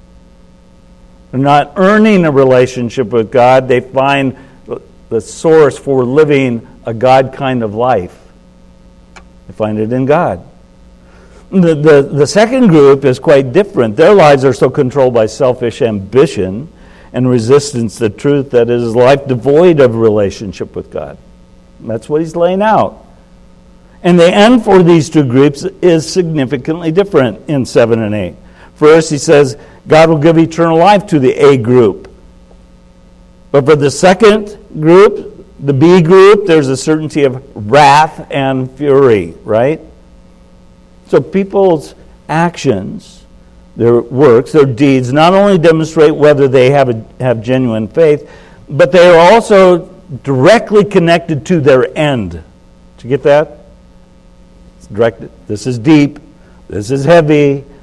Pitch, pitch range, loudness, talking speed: 140 Hz, 120-165 Hz, -9 LUFS, 140 wpm